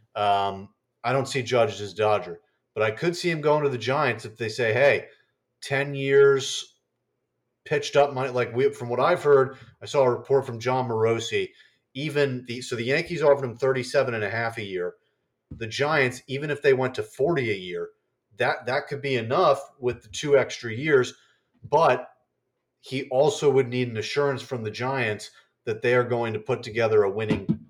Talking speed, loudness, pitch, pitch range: 195 wpm, -24 LUFS, 130 Hz, 115-140 Hz